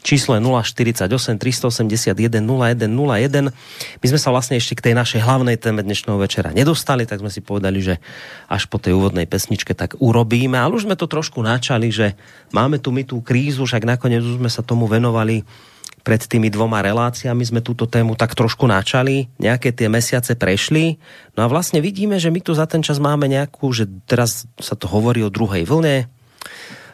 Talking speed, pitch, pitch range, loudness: 185 wpm, 120 Hz, 110-135 Hz, -18 LUFS